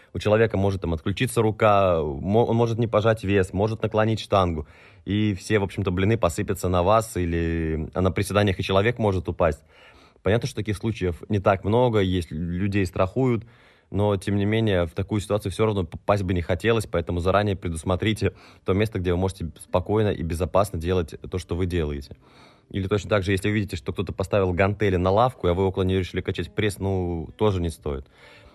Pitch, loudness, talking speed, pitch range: 100 Hz, -24 LUFS, 195 wpm, 90-105 Hz